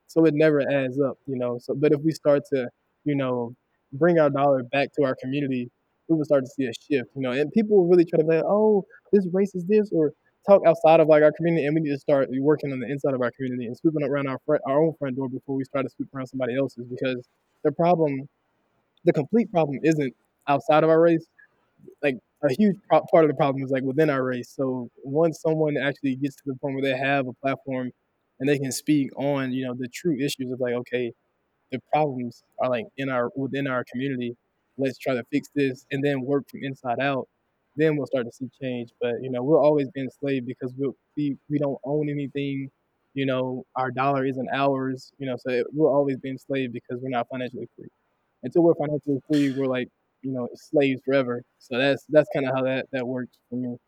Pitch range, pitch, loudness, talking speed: 130-150 Hz, 135 Hz, -24 LUFS, 230 wpm